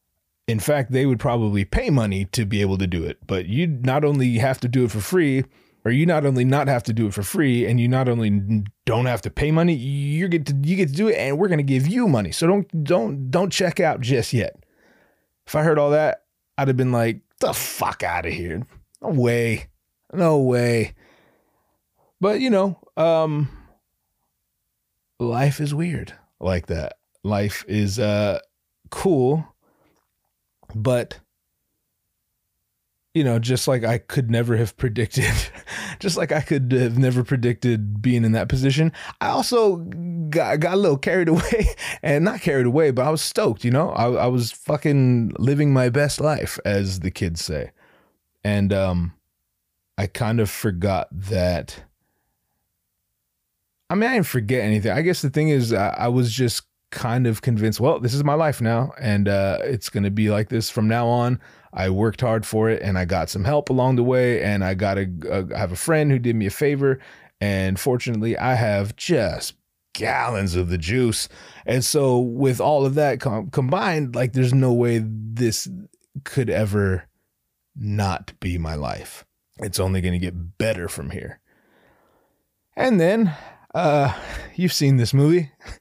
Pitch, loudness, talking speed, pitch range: 125 Hz, -21 LUFS, 180 wpm, 105-145 Hz